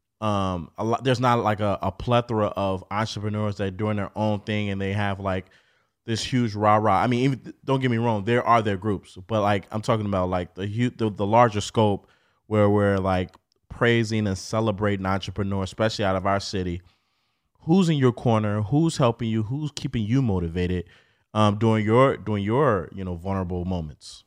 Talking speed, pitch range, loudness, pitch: 195 wpm, 95-115 Hz, -24 LUFS, 105 Hz